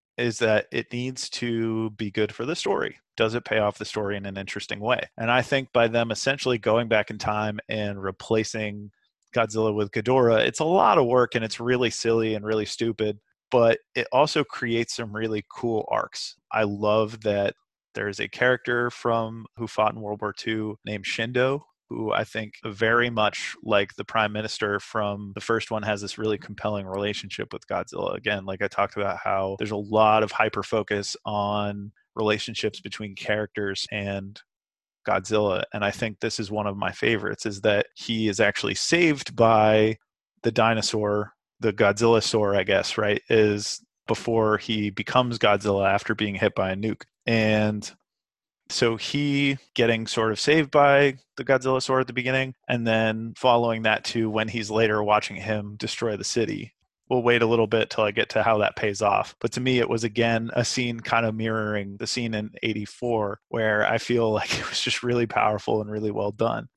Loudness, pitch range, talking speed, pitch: -24 LUFS, 105-115 Hz, 190 wpm, 110 Hz